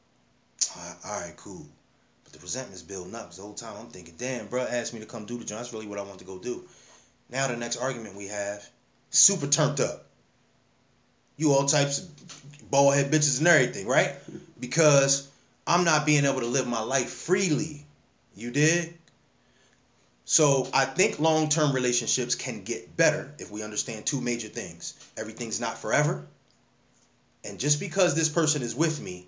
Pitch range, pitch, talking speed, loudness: 115-155 Hz, 135 Hz, 180 wpm, -26 LUFS